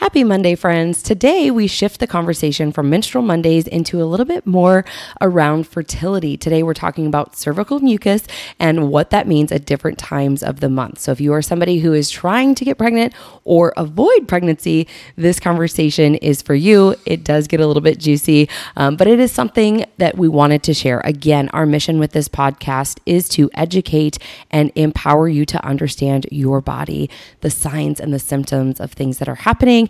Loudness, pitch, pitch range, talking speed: -15 LUFS, 160 Hz, 150-180 Hz, 195 wpm